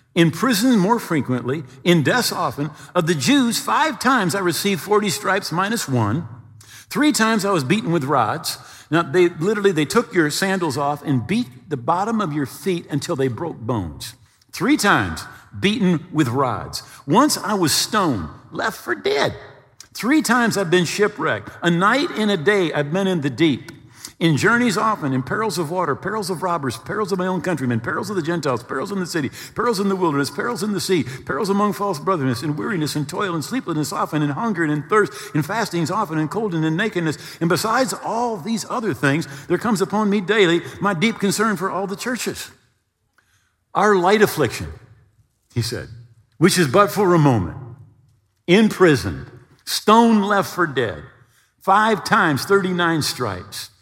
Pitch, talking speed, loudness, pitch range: 180 Hz, 185 wpm, -20 LUFS, 145-205 Hz